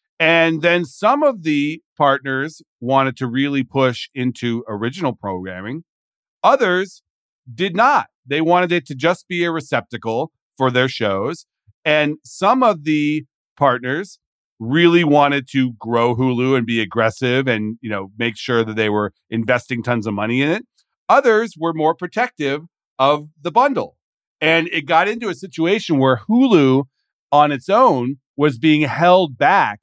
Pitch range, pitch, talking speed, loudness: 125-165 Hz, 140 Hz, 155 wpm, -17 LUFS